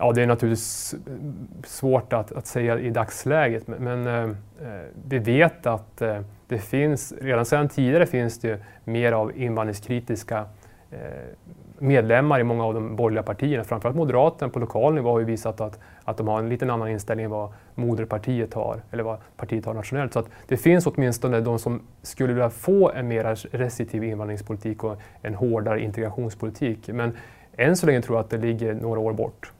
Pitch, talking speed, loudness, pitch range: 115 Hz, 175 wpm, -24 LUFS, 110-125 Hz